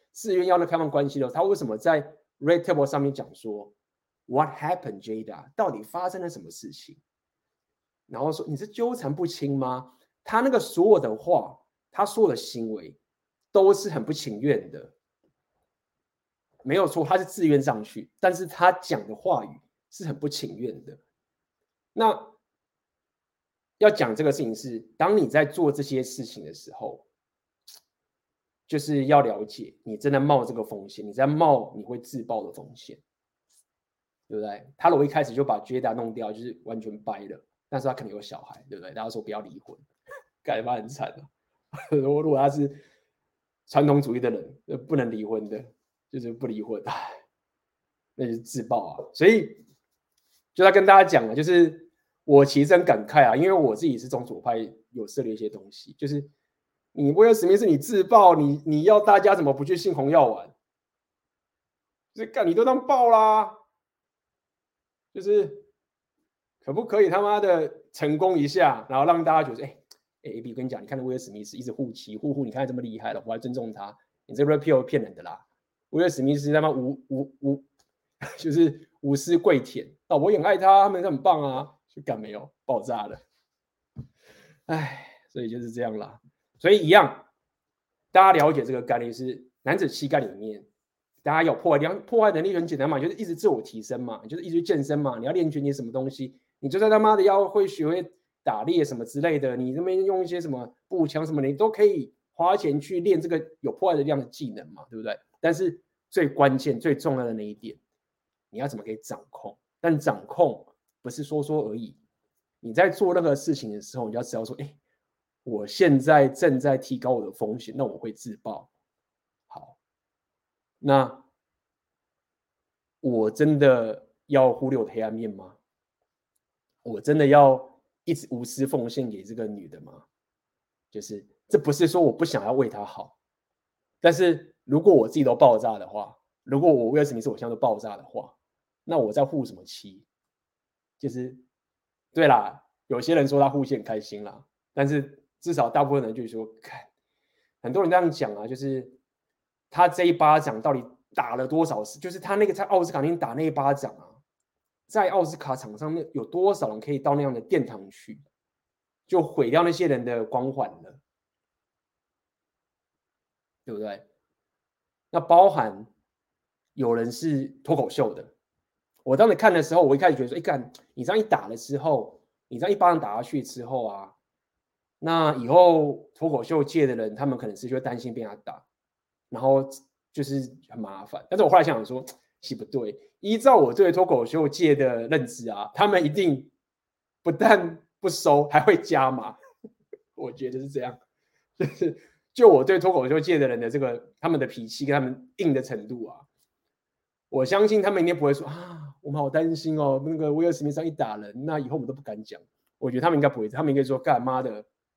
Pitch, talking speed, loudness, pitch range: 145 Hz, 275 characters per minute, -23 LUFS, 130-170 Hz